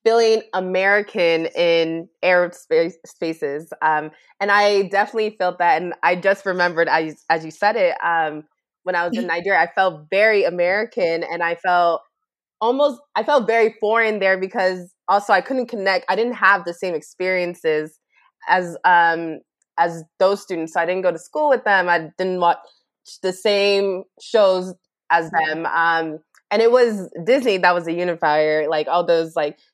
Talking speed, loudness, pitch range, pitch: 170 wpm, -19 LUFS, 165-200 Hz, 180 Hz